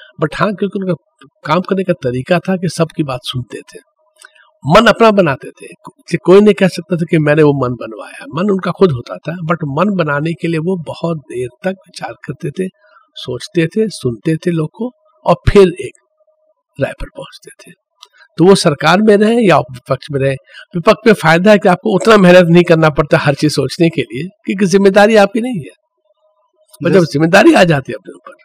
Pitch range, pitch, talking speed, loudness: 155-205 Hz, 180 Hz, 210 wpm, -12 LUFS